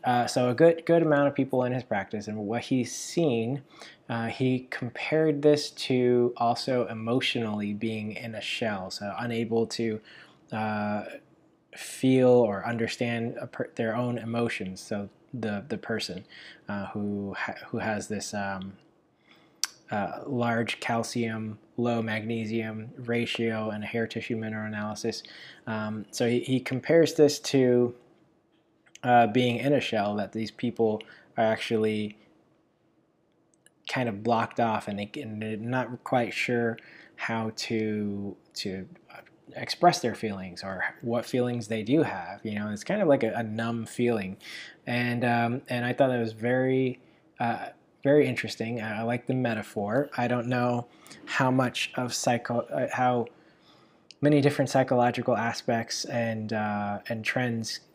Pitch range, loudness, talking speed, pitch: 110-125 Hz, -28 LUFS, 145 wpm, 120 Hz